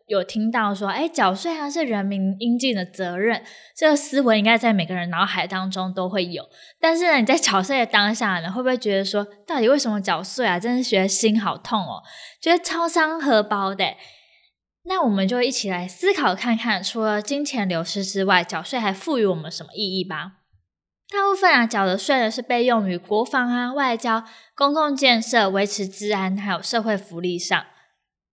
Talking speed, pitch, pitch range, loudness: 290 characters per minute, 215 Hz, 190-255 Hz, -21 LUFS